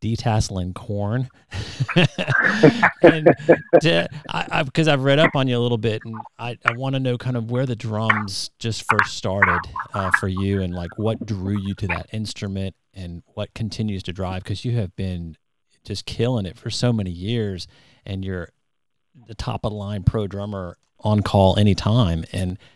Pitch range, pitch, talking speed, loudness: 95-120 Hz, 110 Hz, 180 wpm, -21 LUFS